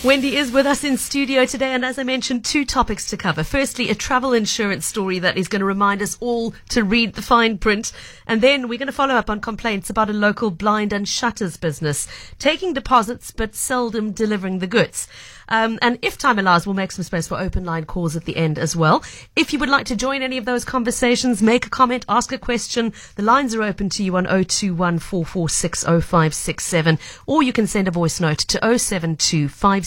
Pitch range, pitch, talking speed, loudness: 185-250 Hz, 220 Hz, 235 wpm, -19 LUFS